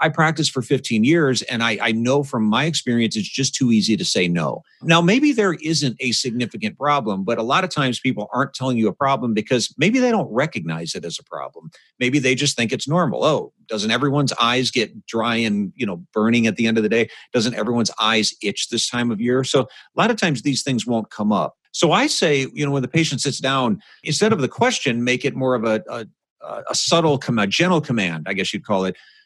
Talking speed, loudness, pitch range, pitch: 240 wpm, -19 LUFS, 115-145 Hz, 125 Hz